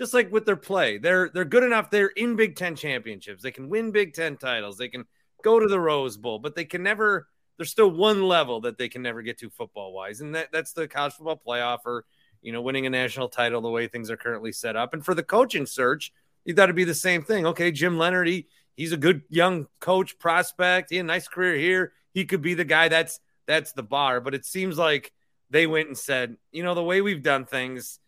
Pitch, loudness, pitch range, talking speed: 165 Hz, -24 LUFS, 130-185 Hz, 245 wpm